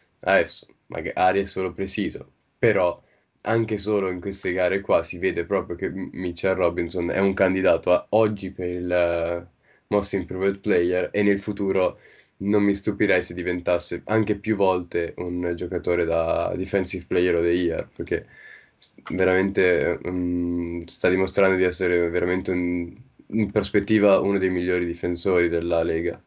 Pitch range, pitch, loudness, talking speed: 90-100 Hz, 90 Hz, -23 LUFS, 150 wpm